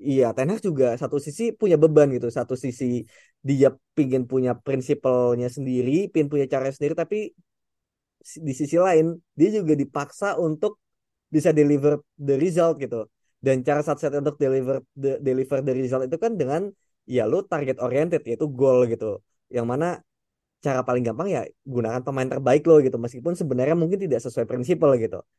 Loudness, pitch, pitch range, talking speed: -23 LUFS, 140 Hz, 130-160 Hz, 165 wpm